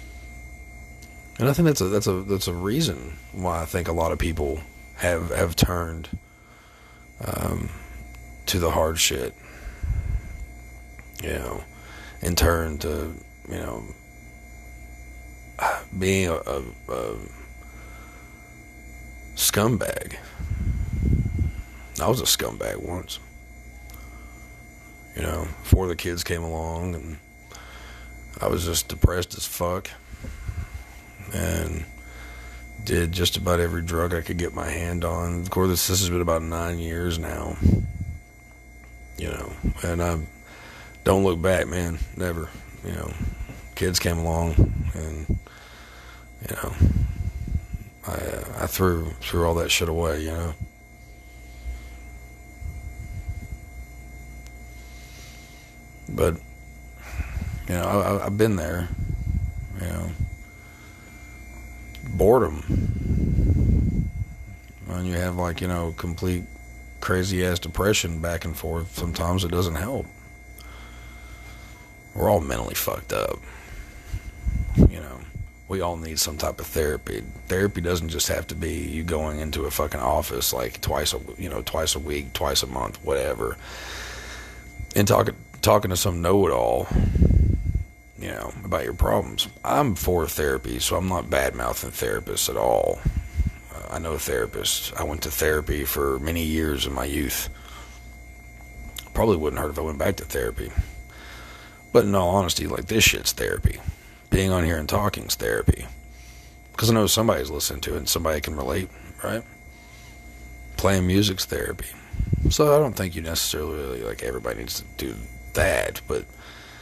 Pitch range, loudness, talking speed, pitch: 65-90 Hz, -25 LUFS, 135 wpm, 80 Hz